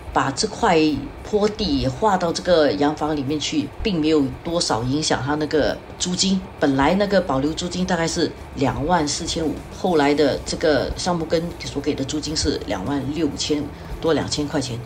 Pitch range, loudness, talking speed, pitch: 145-175 Hz, -21 LUFS, 265 characters per minute, 155 Hz